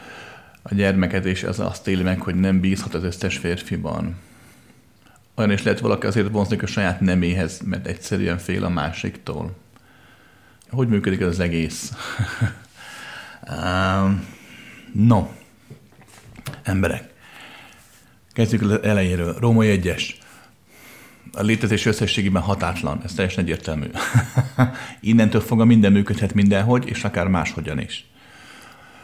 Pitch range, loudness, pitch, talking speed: 90-110 Hz, -21 LUFS, 100 Hz, 115 wpm